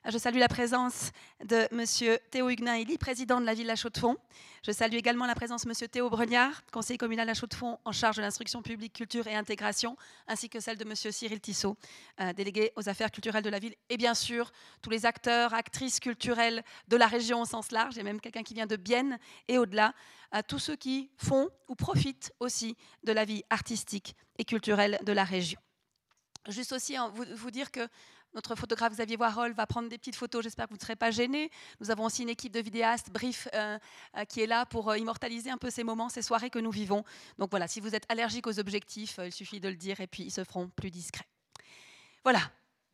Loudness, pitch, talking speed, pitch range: -32 LUFS, 230 Hz, 220 wpm, 215-240 Hz